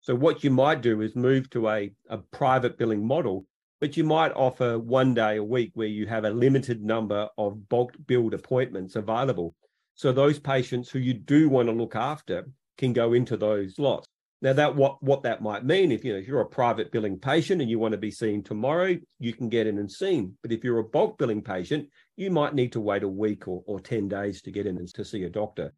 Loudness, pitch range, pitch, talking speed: -26 LUFS, 105-135 Hz, 120 Hz, 235 wpm